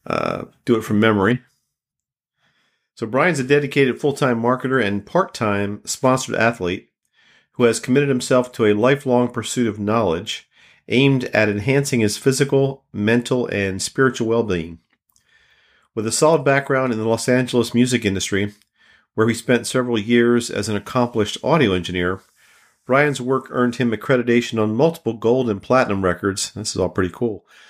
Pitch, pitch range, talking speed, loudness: 120 Hz, 105-130 Hz, 150 wpm, -19 LUFS